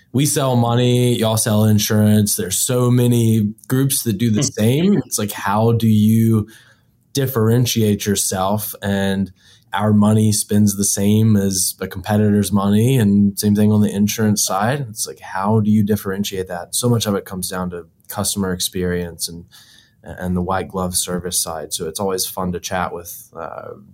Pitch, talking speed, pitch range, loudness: 105 Hz, 175 wpm, 95-115 Hz, -17 LUFS